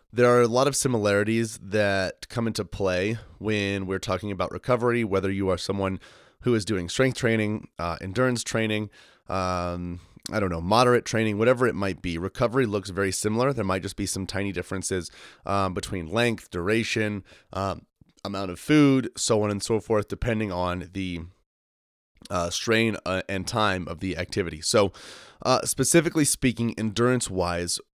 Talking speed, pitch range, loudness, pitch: 165 wpm, 95-115 Hz, -25 LUFS, 100 Hz